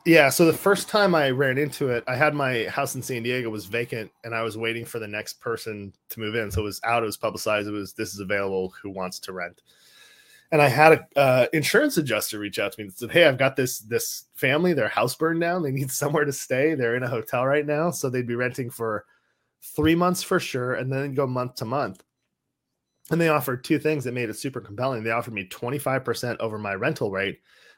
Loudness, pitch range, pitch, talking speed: -24 LUFS, 115-150 Hz, 130 Hz, 240 wpm